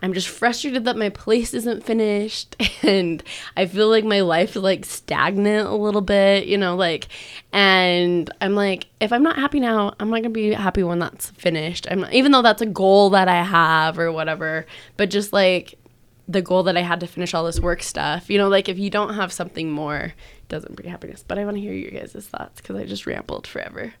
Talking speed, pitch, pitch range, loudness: 230 wpm, 195 Hz, 175-210 Hz, -20 LUFS